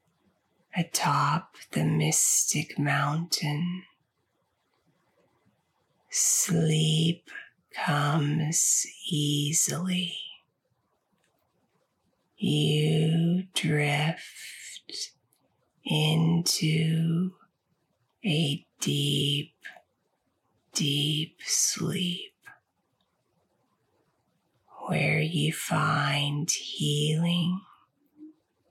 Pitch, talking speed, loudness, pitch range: 160 Hz, 40 wpm, -26 LUFS, 150-175 Hz